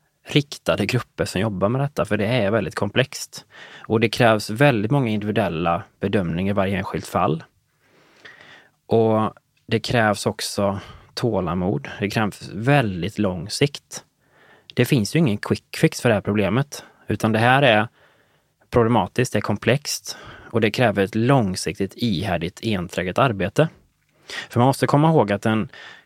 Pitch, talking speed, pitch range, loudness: 110 Hz, 150 wpm, 100-125 Hz, -21 LUFS